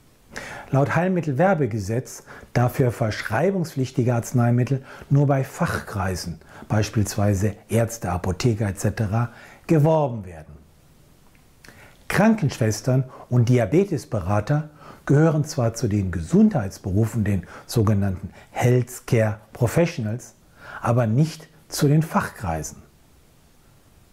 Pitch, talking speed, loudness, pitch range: 120 Hz, 80 wpm, -22 LUFS, 105-145 Hz